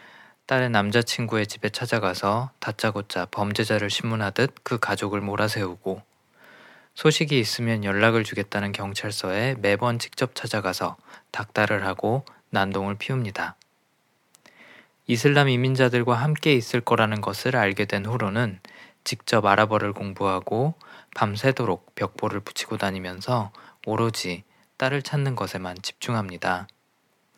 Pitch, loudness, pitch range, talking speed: 110 Hz, -25 LUFS, 100-125 Hz, 290 characters per minute